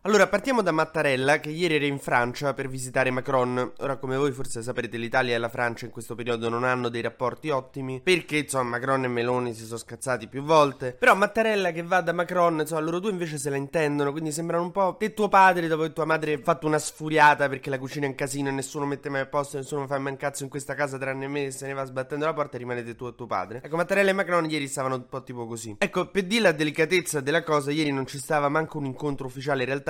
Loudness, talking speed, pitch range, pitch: -25 LUFS, 260 wpm, 130-160 Hz, 140 Hz